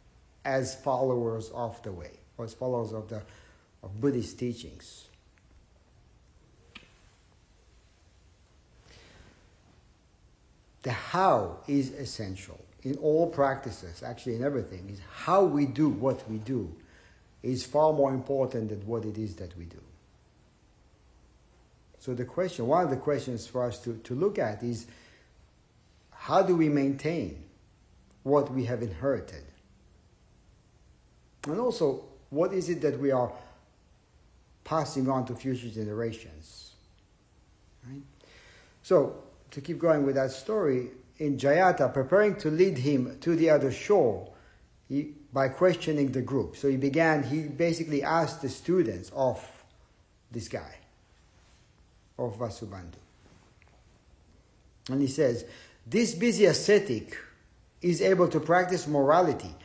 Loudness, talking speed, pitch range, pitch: -28 LUFS, 125 wpm, 100-145 Hz, 125 Hz